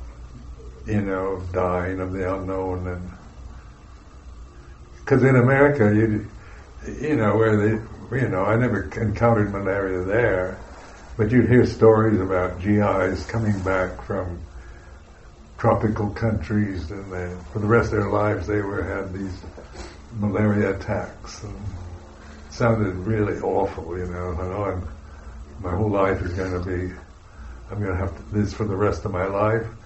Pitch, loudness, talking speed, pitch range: 95 Hz, -22 LUFS, 145 wpm, 90-105 Hz